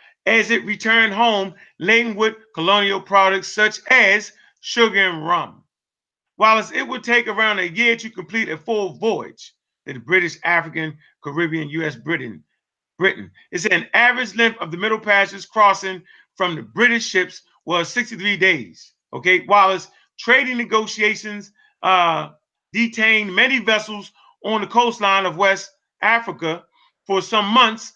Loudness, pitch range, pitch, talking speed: -17 LUFS, 185-225 Hz, 205 Hz, 145 wpm